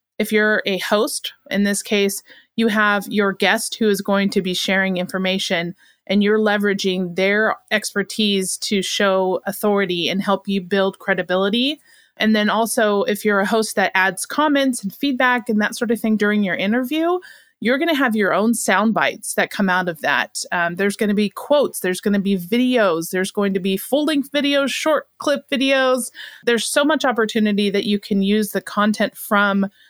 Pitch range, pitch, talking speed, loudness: 195-235 Hz, 205 Hz, 195 wpm, -19 LUFS